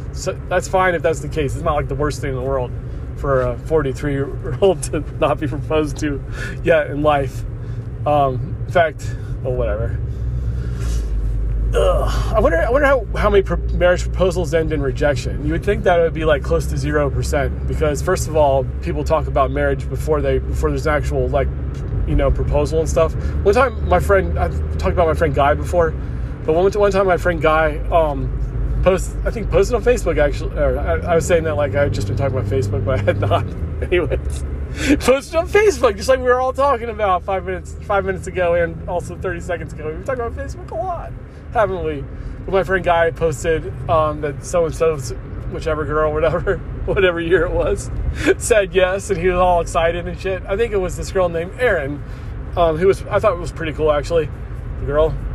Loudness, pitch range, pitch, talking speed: -19 LUFS, 115-175 Hz, 150 Hz, 215 wpm